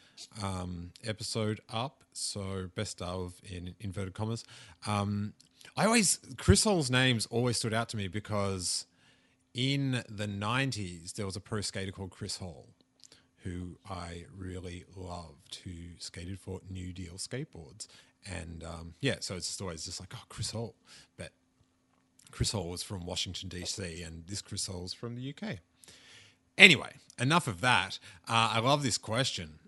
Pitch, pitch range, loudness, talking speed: 100 Hz, 90-115 Hz, -31 LUFS, 155 wpm